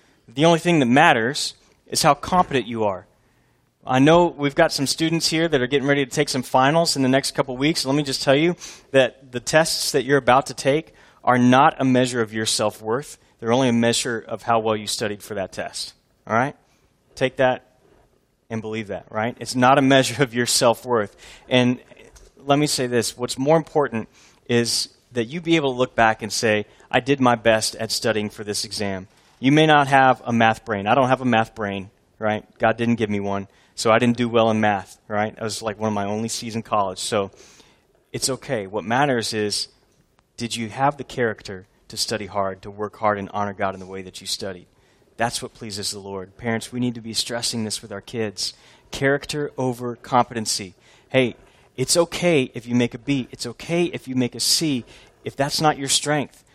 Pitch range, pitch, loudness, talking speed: 110-135 Hz, 120 Hz, -21 LUFS, 220 wpm